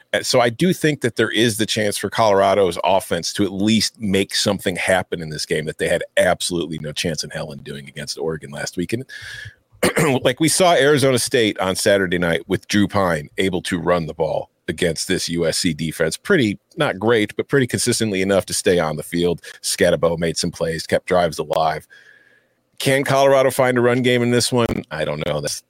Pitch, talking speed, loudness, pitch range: 105 Hz, 205 wpm, -19 LUFS, 85-125 Hz